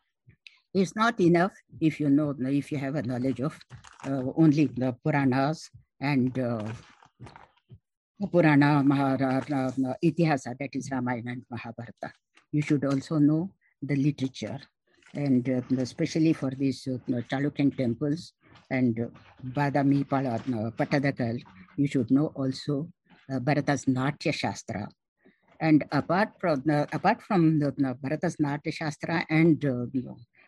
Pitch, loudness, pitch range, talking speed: 140 Hz, -27 LUFS, 130-155 Hz, 130 wpm